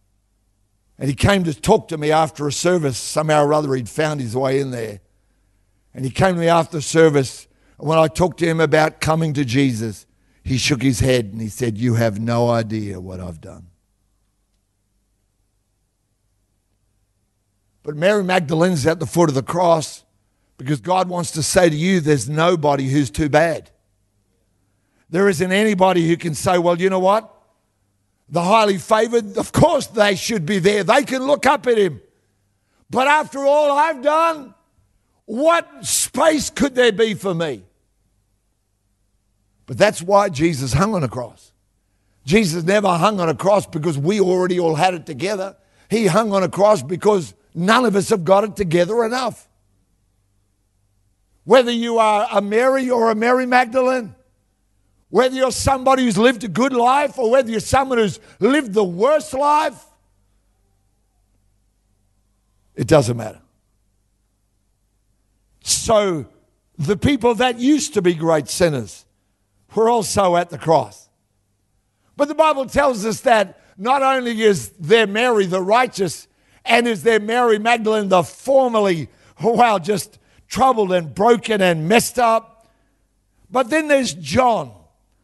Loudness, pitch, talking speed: -17 LUFS, 160 Hz, 155 wpm